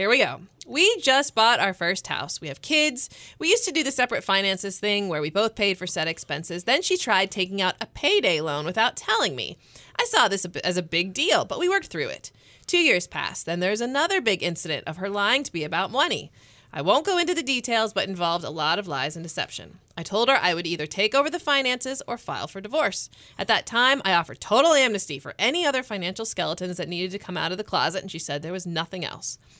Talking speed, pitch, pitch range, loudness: 245 wpm, 195 Hz, 175-265 Hz, -24 LUFS